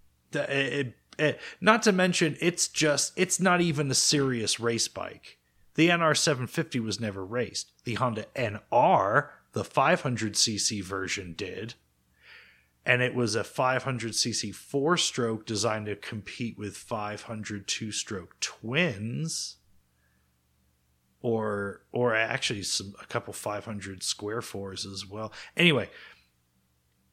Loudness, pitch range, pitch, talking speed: -28 LUFS, 100-140 Hz, 110 Hz, 120 wpm